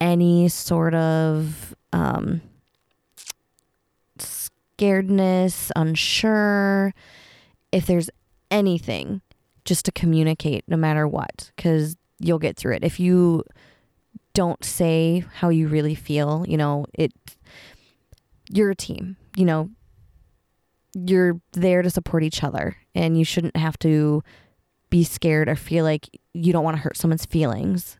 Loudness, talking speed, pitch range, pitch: -22 LUFS, 125 wpm, 155-180 Hz, 165 Hz